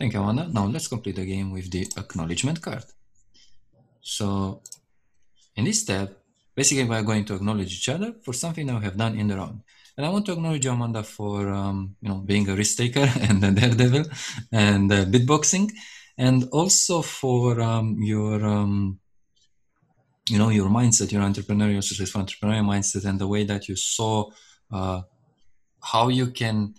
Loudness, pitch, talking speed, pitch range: -23 LUFS, 105 Hz, 175 wpm, 100-125 Hz